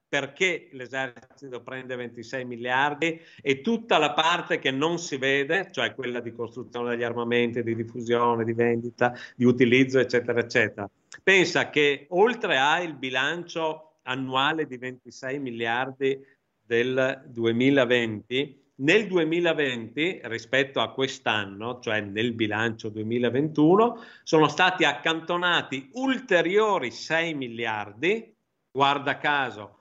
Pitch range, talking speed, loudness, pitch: 120-150 Hz, 115 wpm, -25 LUFS, 130 Hz